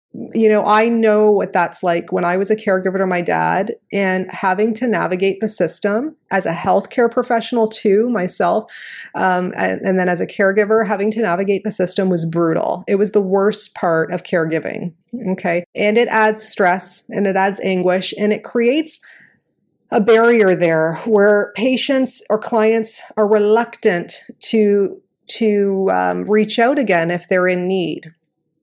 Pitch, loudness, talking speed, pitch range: 205 Hz, -16 LUFS, 165 wpm, 180-220 Hz